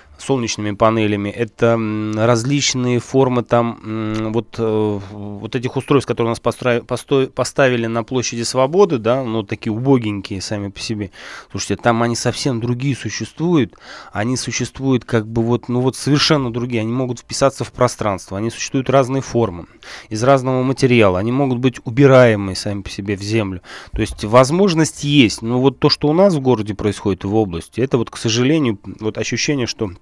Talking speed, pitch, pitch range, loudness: 165 wpm, 120 Hz, 110-130 Hz, -17 LUFS